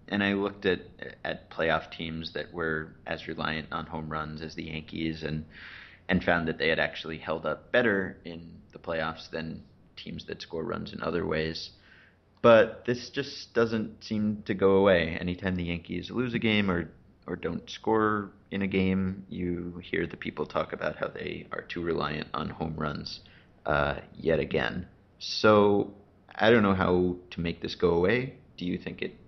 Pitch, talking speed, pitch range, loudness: 90 Hz, 185 wpm, 80-100 Hz, -29 LUFS